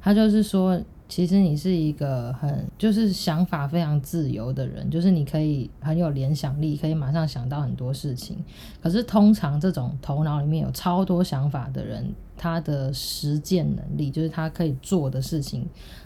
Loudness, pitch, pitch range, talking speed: -24 LUFS, 155 Hz, 140-180 Hz, 275 characters per minute